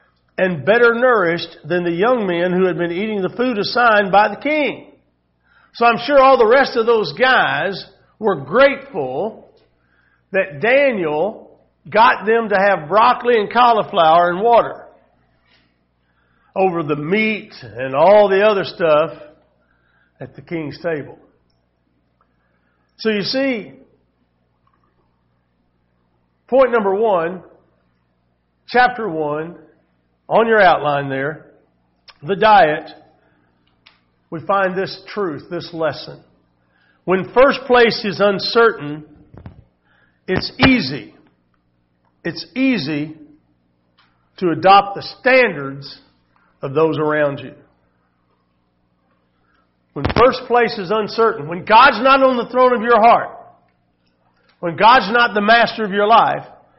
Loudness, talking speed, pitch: -15 LUFS, 115 wpm, 160 Hz